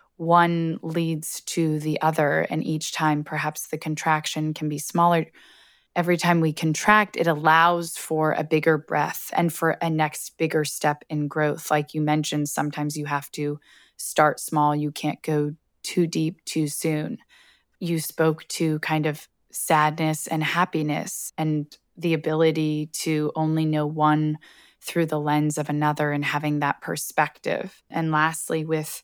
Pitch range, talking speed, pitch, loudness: 150-160 Hz, 155 wpm, 155 Hz, -24 LUFS